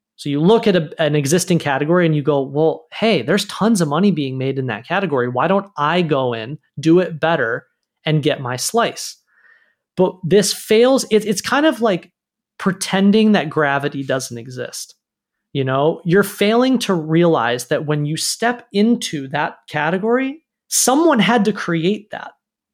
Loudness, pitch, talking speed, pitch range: -17 LUFS, 175 Hz, 170 wpm, 150-215 Hz